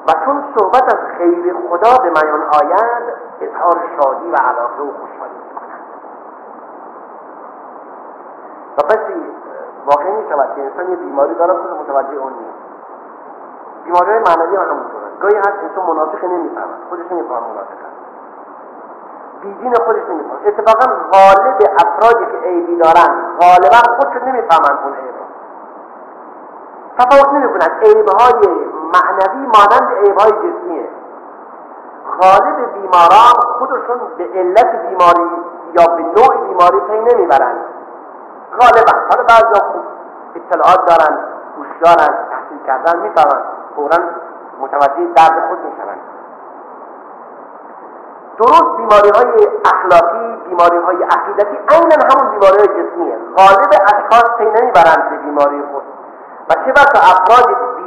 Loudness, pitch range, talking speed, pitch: -11 LUFS, 170-230 Hz, 120 wpm, 190 Hz